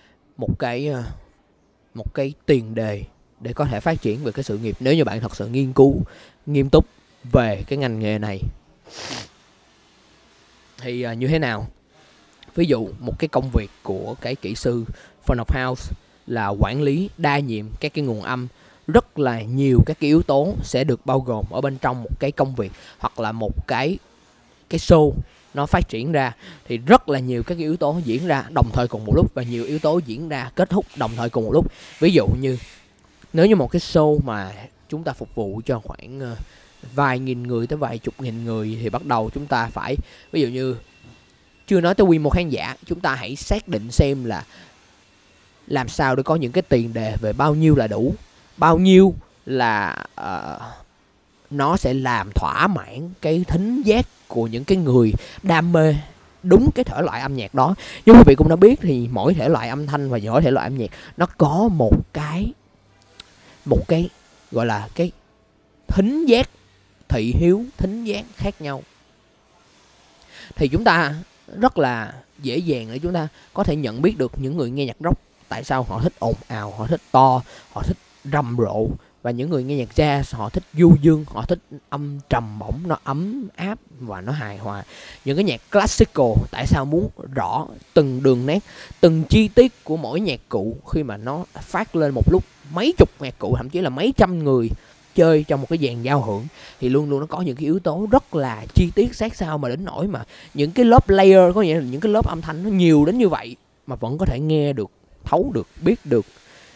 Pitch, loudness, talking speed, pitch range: 140 Hz, -20 LUFS, 210 wpm, 120-165 Hz